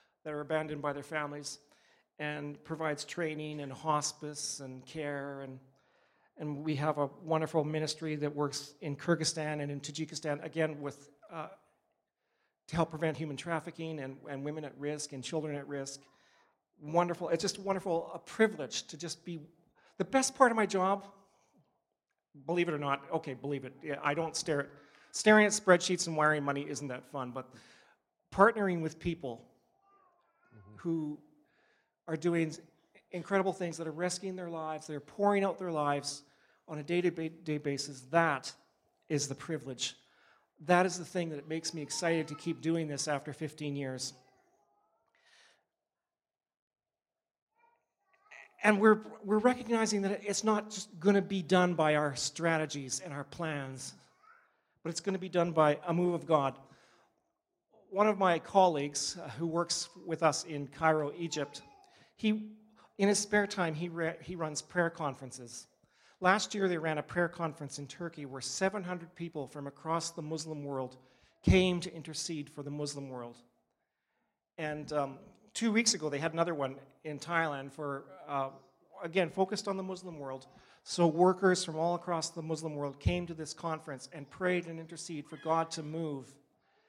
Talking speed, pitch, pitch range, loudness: 165 wpm, 160 Hz, 145-175 Hz, -33 LUFS